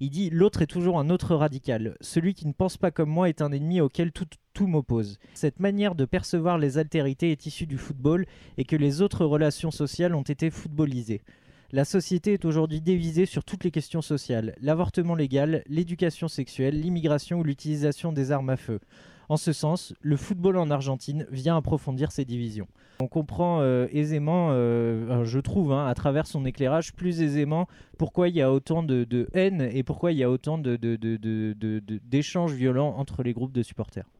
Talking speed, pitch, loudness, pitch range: 200 wpm, 150 Hz, -26 LUFS, 130-170 Hz